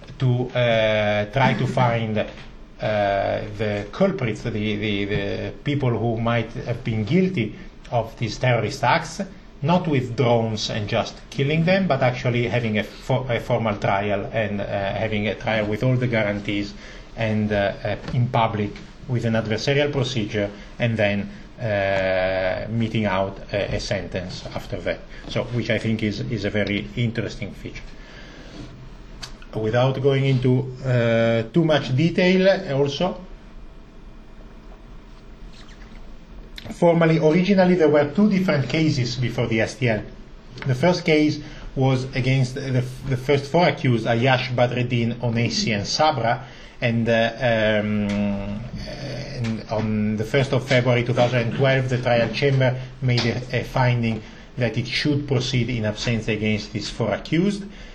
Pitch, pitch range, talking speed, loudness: 120 Hz, 110-140 Hz, 140 wpm, -22 LUFS